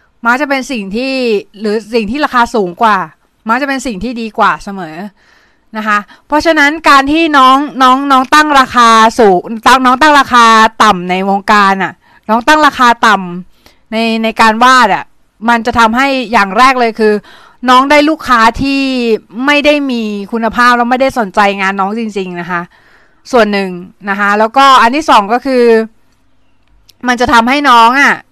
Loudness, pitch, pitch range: -9 LUFS, 235 Hz, 210-265 Hz